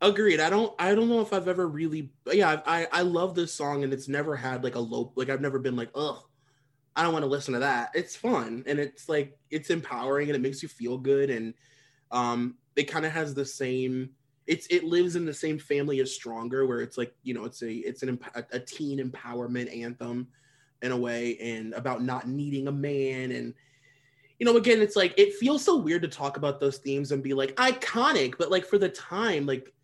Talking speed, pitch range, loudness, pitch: 230 wpm, 130-160 Hz, -28 LUFS, 140 Hz